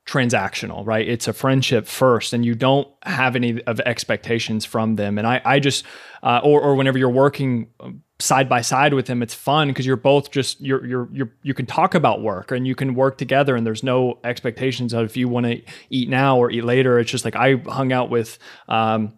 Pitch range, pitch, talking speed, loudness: 120-135 Hz, 125 Hz, 220 wpm, -19 LUFS